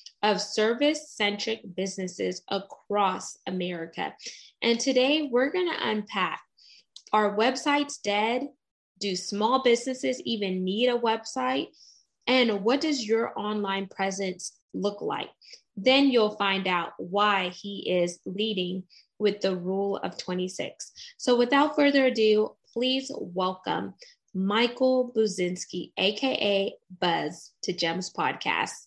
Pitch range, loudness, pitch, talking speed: 190-250 Hz, -27 LUFS, 210 Hz, 115 wpm